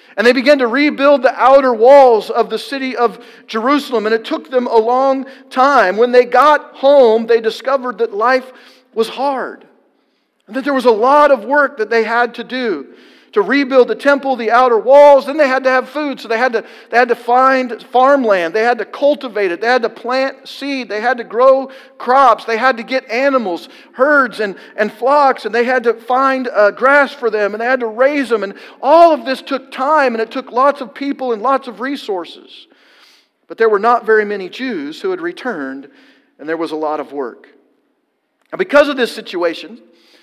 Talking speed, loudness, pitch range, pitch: 210 wpm, -13 LUFS, 225-270 Hz, 255 Hz